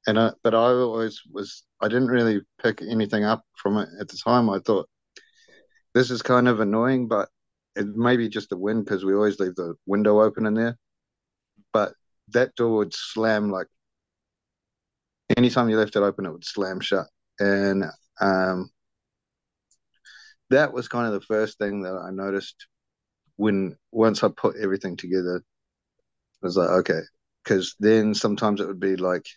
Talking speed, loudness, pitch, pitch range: 170 wpm, -23 LUFS, 110 Hz, 100-115 Hz